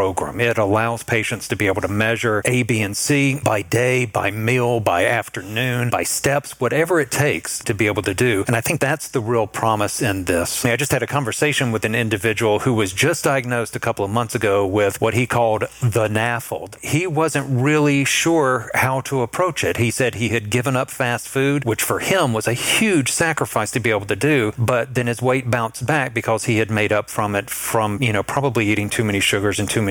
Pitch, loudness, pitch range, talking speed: 120 Hz, -19 LUFS, 110-130 Hz, 230 wpm